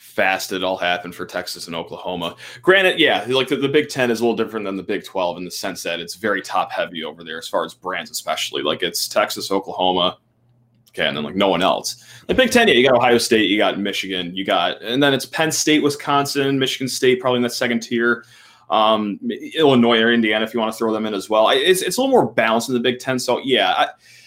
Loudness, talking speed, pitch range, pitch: -19 LUFS, 250 wpm, 100-135 Hz, 120 Hz